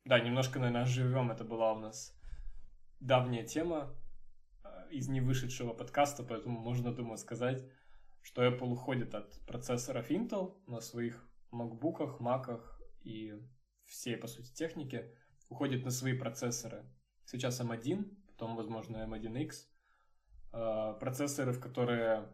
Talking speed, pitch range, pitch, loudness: 120 wpm, 115-130 Hz, 120 Hz, -38 LUFS